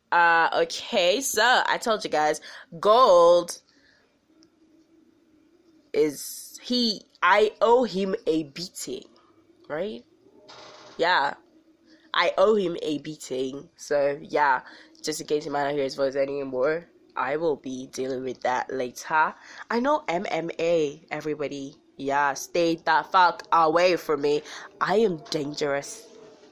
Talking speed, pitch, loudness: 125 wpm, 175 Hz, -24 LUFS